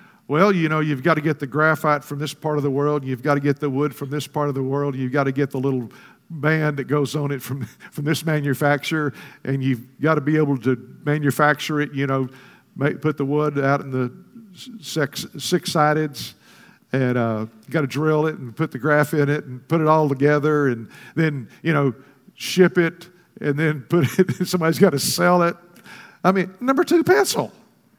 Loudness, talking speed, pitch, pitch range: -21 LUFS, 215 wpm, 150 Hz, 140-160 Hz